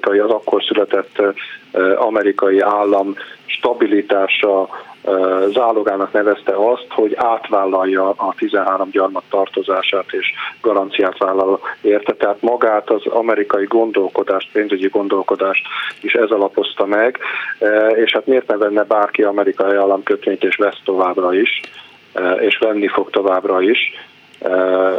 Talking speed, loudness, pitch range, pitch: 120 wpm, -16 LUFS, 95-105 Hz, 100 Hz